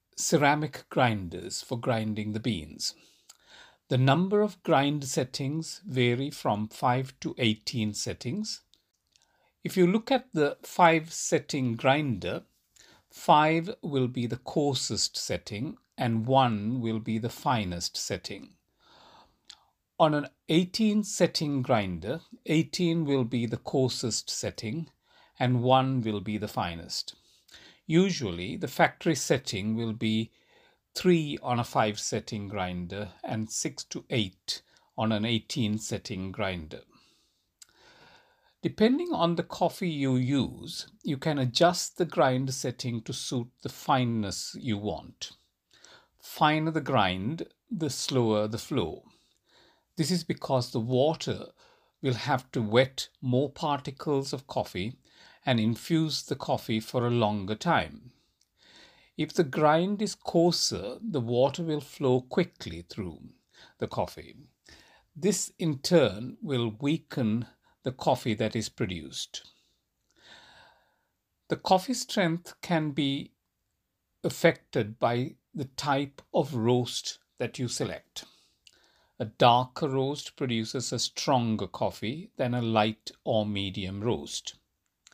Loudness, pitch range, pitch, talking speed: -29 LUFS, 110-160 Hz, 130 Hz, 120 wpm